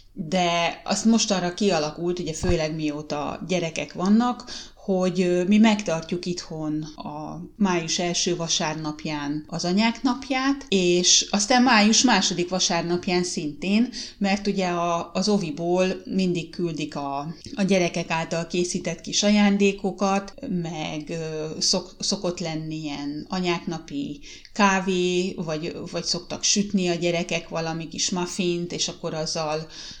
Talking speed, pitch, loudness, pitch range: 120 wpm, 175 Hz, -23 LUFS, 160-195 Hz